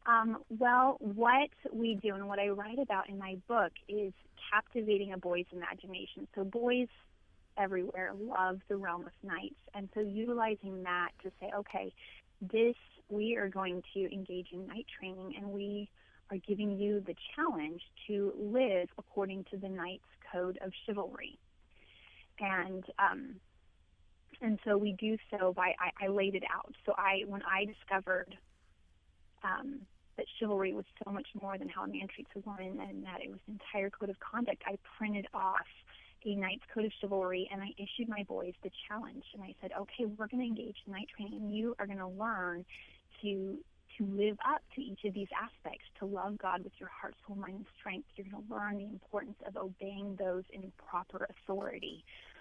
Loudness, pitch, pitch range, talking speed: -37 LUFS, 200 Hz, 185-215 Hz, 185 wpm